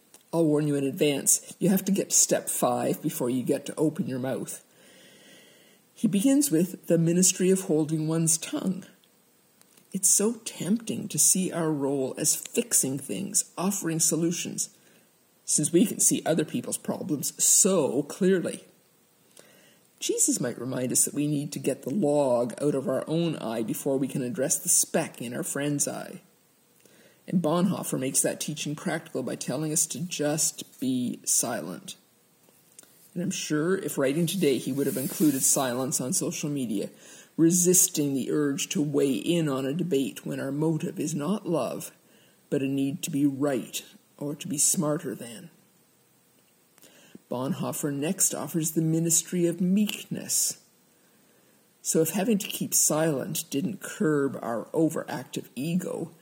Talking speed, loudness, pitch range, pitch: 155 wpm, -26 LUFS, 145-185 Hz, 160 Hz